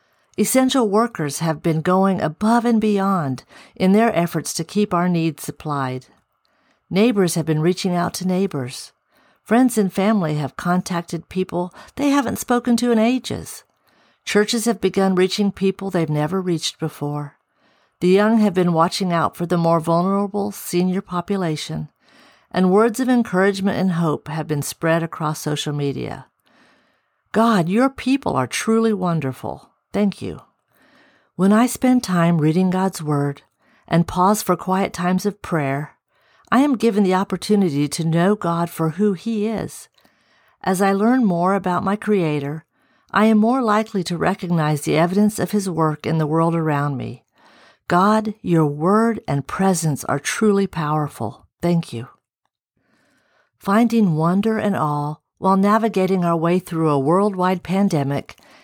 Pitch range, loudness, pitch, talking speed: 160-210 Hz, -19 LUFS, 185 Hz, 150 wpm